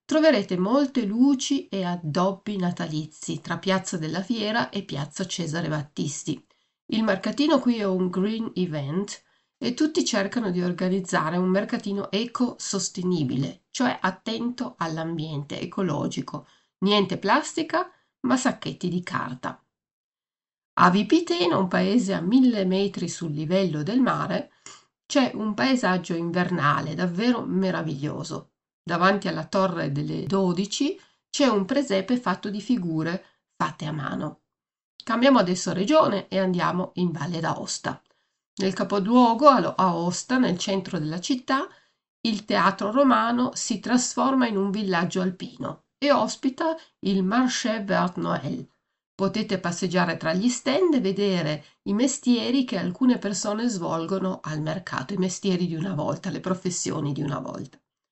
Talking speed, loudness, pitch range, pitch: 130 wpm, -25 LUFS, 180-240 Hz, 195 Hz